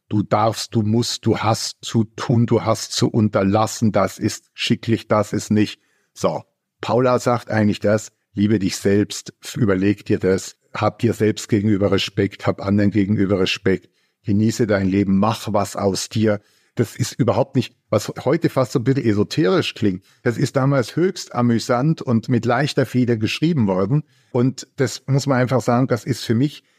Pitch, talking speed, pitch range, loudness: 110 Hz, 175 wpm, 105-125 Hz, -20 LUFS